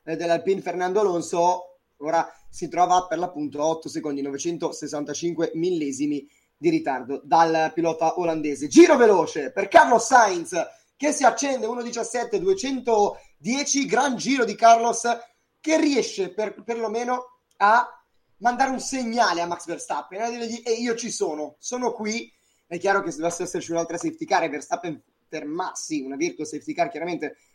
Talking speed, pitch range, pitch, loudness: 145 wpm, 165-245 Hz, 195 Hz, -23 LUFS